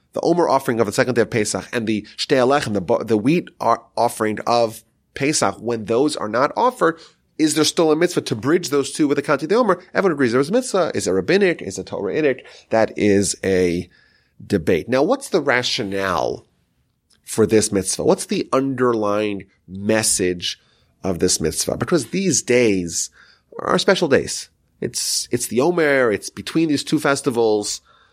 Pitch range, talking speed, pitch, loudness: 100-140 Hz, 190 wpm, 115 Hz, -19 LUFS